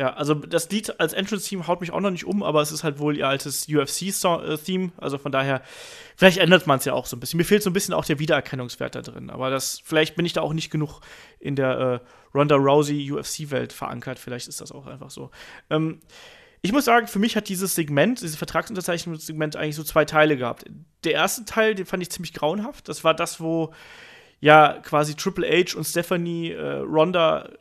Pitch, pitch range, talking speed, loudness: 160 Hz, 145-185 Hz, 220 wpm, -23 LUFS